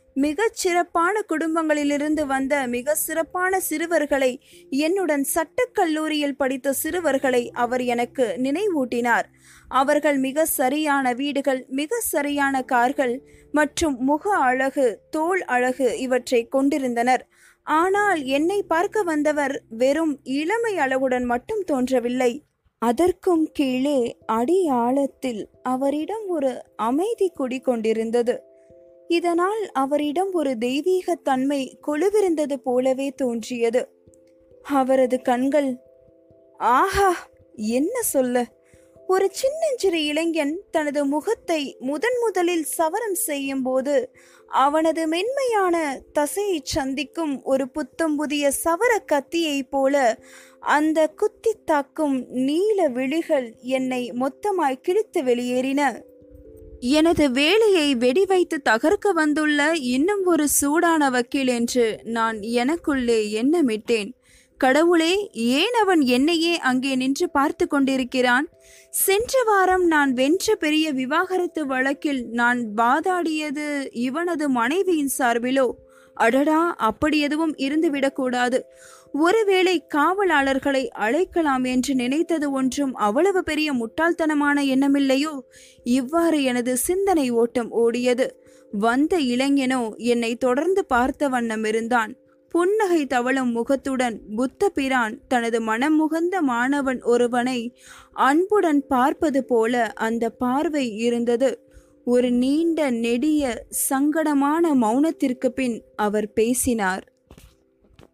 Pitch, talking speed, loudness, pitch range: 280 Hz, 95 wpm, -22 LUFS, 255-330 Hz